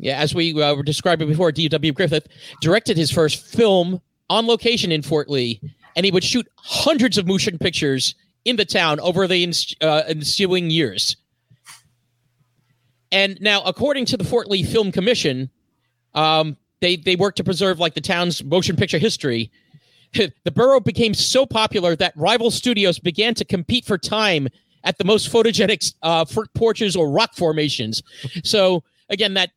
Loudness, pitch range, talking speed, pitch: -19 LUFS, 150-210 Hz, 165 wpm, 175 Hz